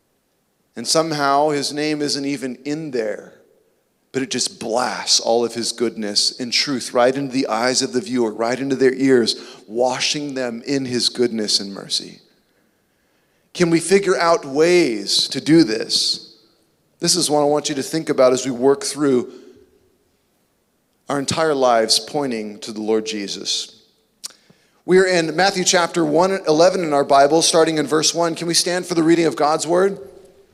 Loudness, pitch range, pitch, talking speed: -18 LUFS, 125-170 Hz, 145 Hz, 170 wpm